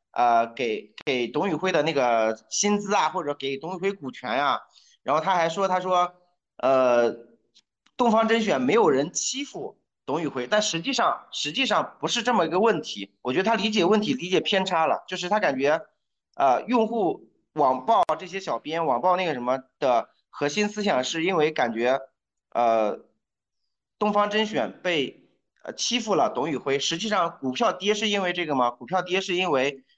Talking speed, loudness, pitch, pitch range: 260 characters per minute, -24 LUFS, 180 Hz, 135-210 Hz